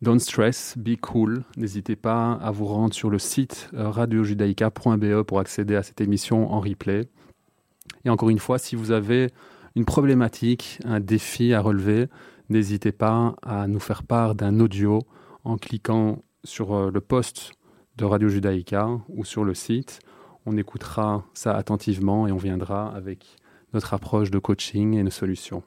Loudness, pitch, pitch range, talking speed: -24 LUFS, 110 Hz, 100-115 Hz, 160 wpm